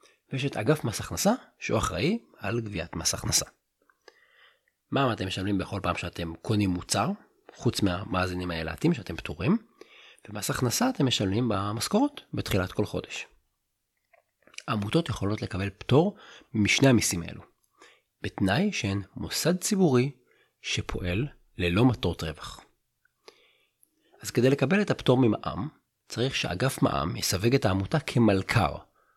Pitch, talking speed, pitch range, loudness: 110 Hz, 125 wpm, 95-140 Hz, -27 LUFS